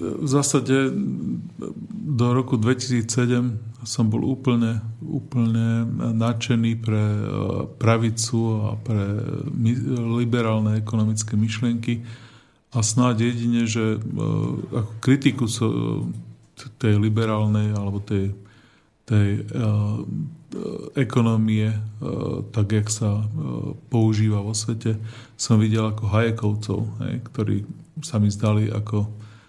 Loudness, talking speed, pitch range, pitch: -23 LUFS, 90 wpm, 110-125 Hz, 115 Hz